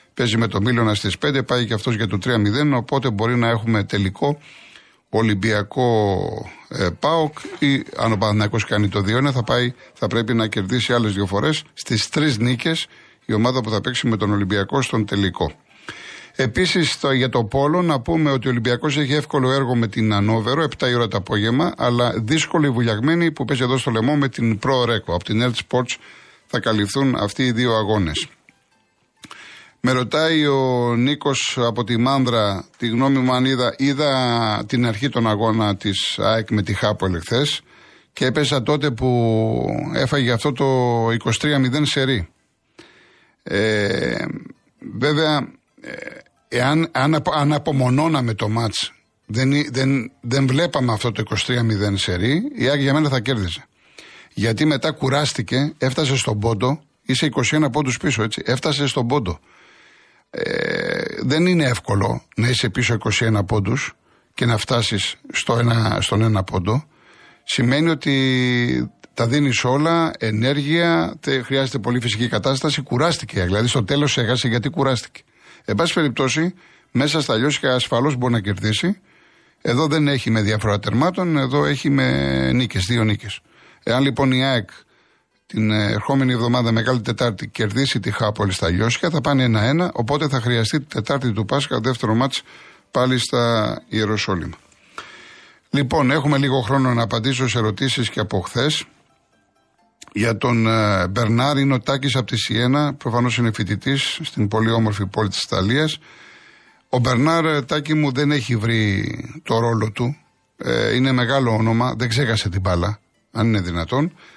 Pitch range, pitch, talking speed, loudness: 110-140 Hz, 125 Hz, 155 wpm, -19 LUFS